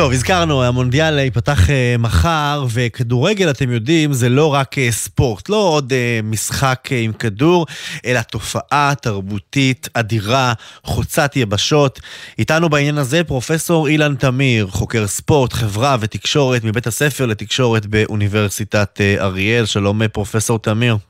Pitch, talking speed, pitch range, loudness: 125 Hz, 115 wpm, 110-145 Hz, -16 LUFS